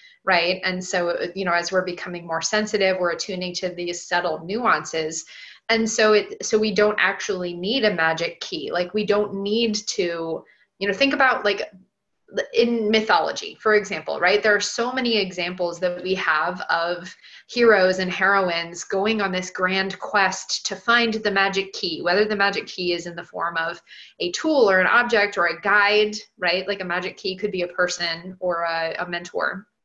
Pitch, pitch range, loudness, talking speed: 190 Hz, 175-210 Hz, -22 LUFS, 190 wpm